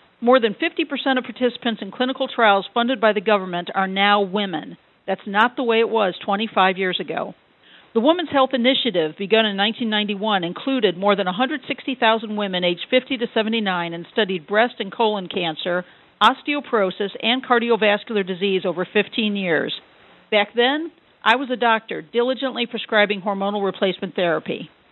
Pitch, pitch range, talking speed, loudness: 220 Hz, 195-245 Hz, 155 wpm, -20 LUFS